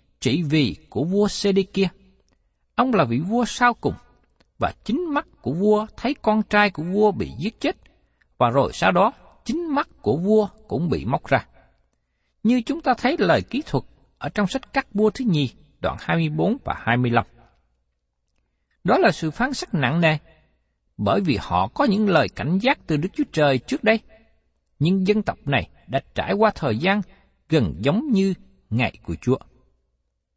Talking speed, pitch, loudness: 190 wpm, 195 Hz, -22 LUFS